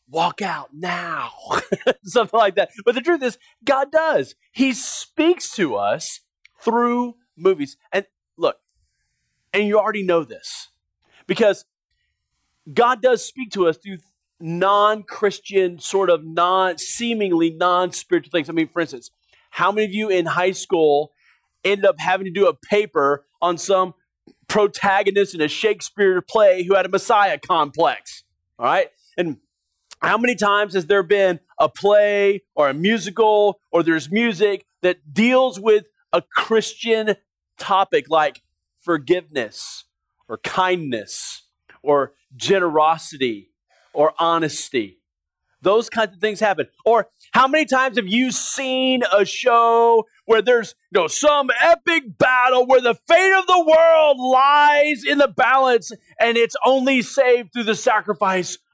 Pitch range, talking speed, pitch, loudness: 180-255 Hz, 140 wpm, 210 Hz, -18 LUFS